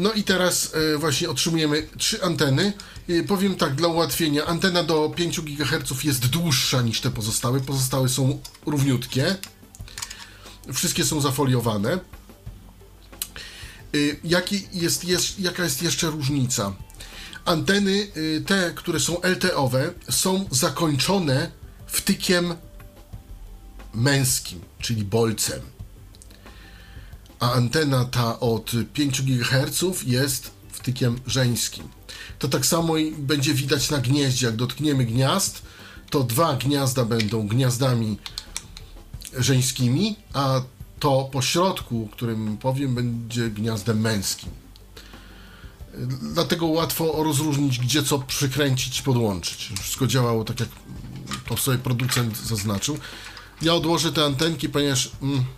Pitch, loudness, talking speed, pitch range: 130 Hz, -23 LUFS, 105 wpm, 110-155 Hz